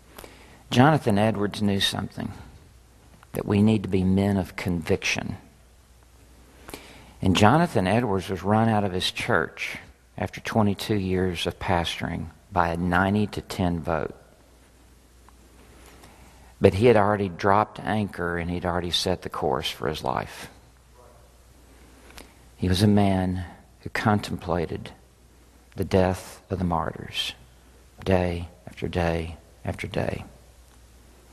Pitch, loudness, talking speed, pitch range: 90 Hz, -25 LUFS, 120 wpm, 70-100 Hz